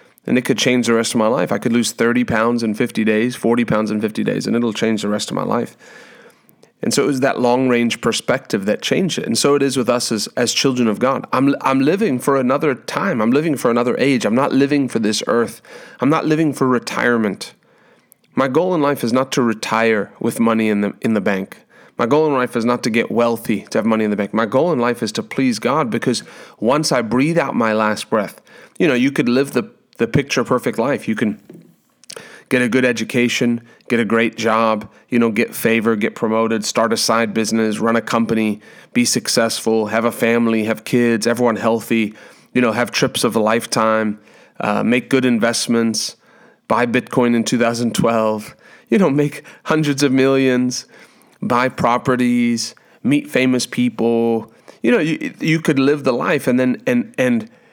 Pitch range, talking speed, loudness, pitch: 115-130 Hz, 205 wpm, -17 LUFS, 120 Hz